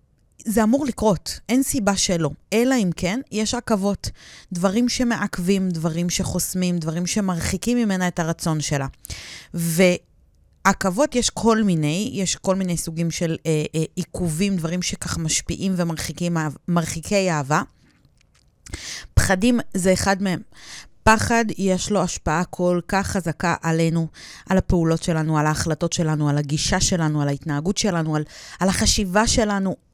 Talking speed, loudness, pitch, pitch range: 135 wpm, -21 LUFS, 180 Hz, 165-200 Hz